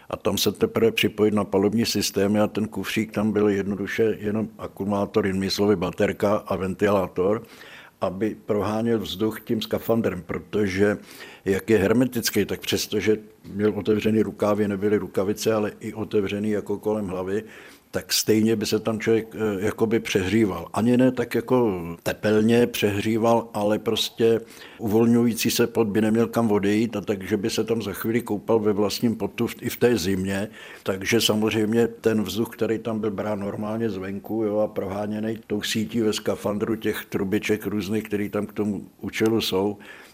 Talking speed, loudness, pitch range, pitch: 160 wpm, -24 LUFS, 105-110 Hz, 105 Hz